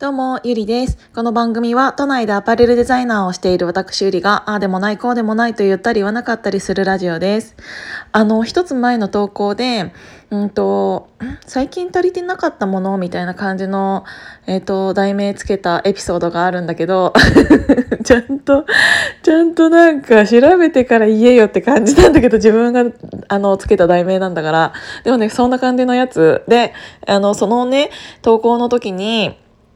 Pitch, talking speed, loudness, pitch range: 220 Hz, 365 characters per minute, -14 LUFS, 195-245 Hz